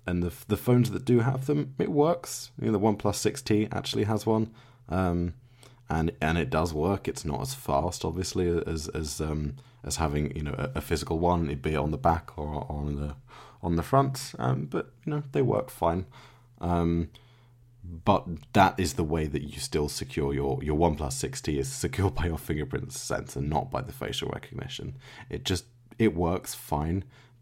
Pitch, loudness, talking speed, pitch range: 90 Hz, -29 LUFS, 195 wpm, 75-120 Hz